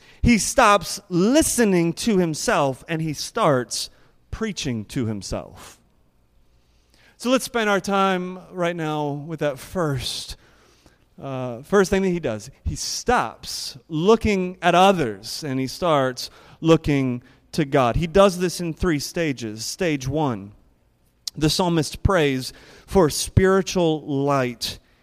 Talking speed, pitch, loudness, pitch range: 125 wpm, 155 Hz, -21 LUFS, 130-180 Hz